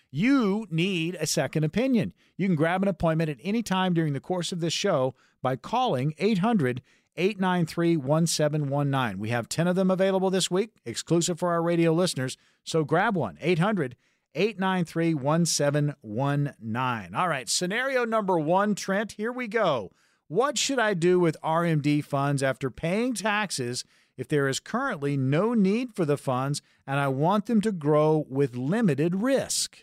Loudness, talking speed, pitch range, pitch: -26 LUFS, 160 wpm, 145-200 Hz, 170 Hz